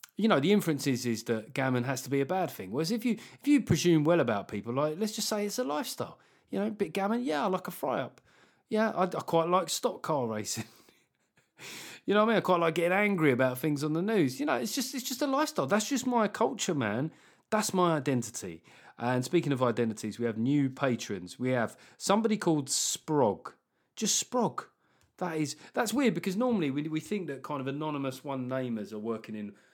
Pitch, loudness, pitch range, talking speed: 165 Hz, -30 LUFS, 130-210 Hz, 225 wpm